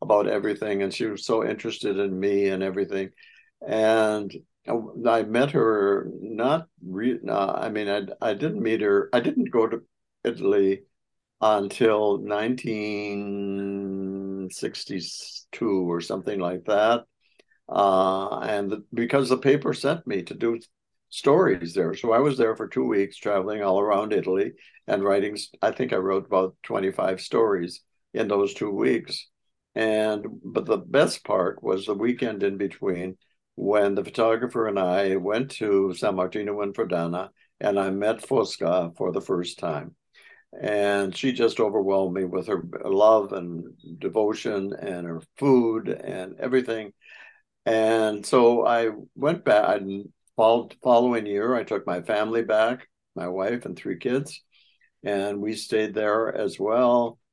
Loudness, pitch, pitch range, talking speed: -25 LUFS, 100 Hz, 95-110 Hz, 150 wpm